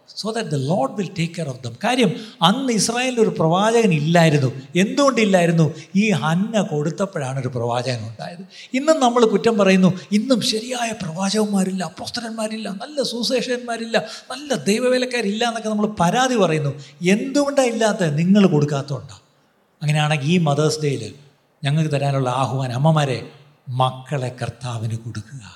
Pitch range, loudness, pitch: 145-225 Hz, -20 LUFS, 180 Hz